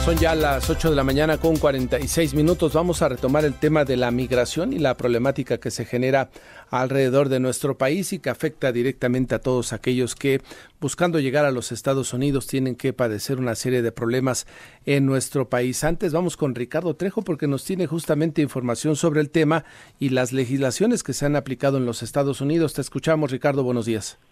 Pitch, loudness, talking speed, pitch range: 135 Hz, -22 LUFS, 205 wpm, 125-155 Hz